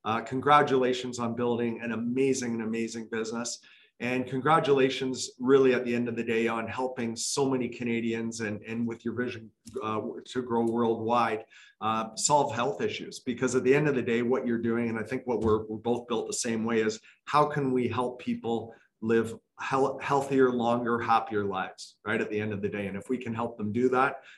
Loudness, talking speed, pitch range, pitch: -28 LUFS, 205 wpm, 115-130 Hz, 120 Hz